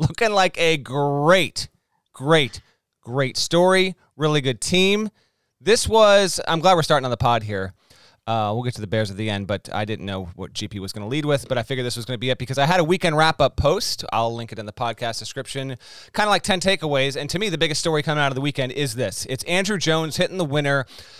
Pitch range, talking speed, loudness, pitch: 115-170 Hz, 250 wpm, -21 LUFS, 140 Hz